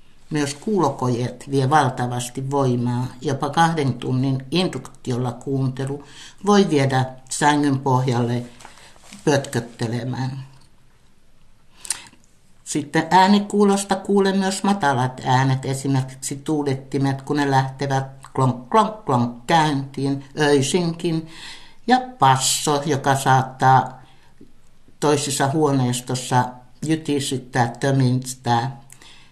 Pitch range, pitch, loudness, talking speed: 130-150 Hz, 135 Hz, -21 LUFS, 80 wpm